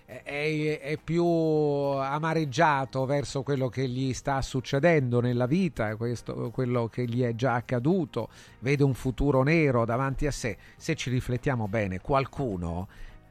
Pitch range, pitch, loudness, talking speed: 120-145 Hz, 130 Hz, -28 LUFS, 140 wpm